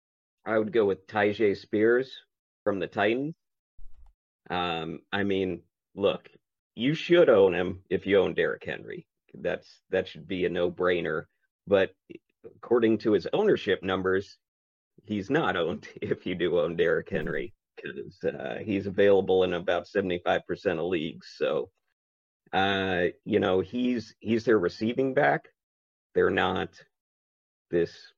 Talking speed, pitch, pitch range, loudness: 135 wpm, 105 Hz, 95-145 Hz, -27 LUFS